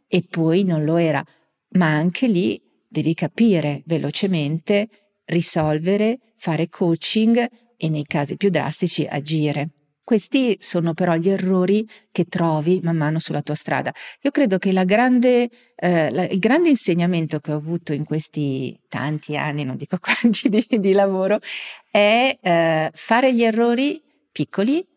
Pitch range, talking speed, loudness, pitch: 155-220 Hz, 145 wpm, -20 LUFS, 180 Hz